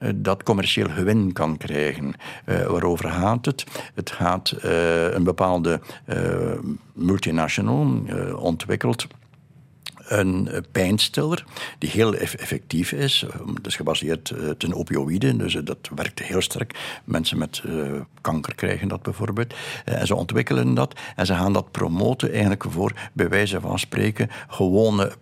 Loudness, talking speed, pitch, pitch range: -23 LUFS, 150 wpm, 100 Hz, 90-120 Hz